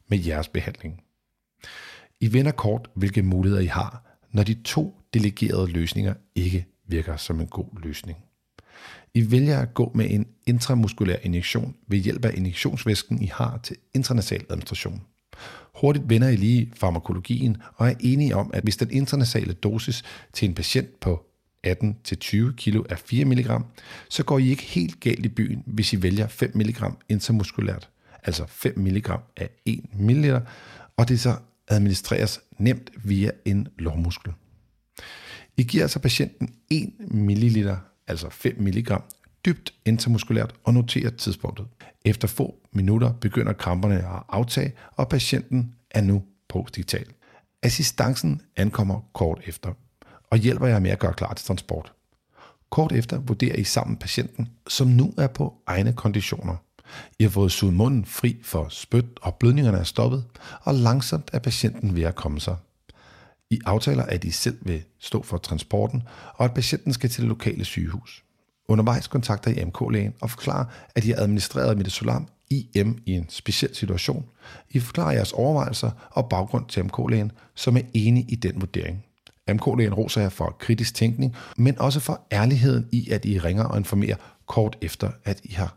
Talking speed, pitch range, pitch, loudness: 160 wpm, 100-120 Hz, 110 Hz, -24 LUFS